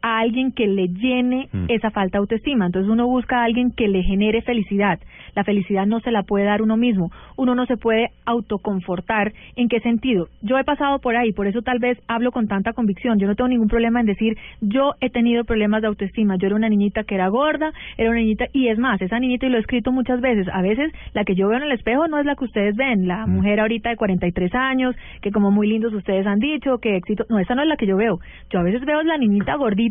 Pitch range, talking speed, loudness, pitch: 205-250 Hz, 255 wpm, -20 LUFS, 225 Hz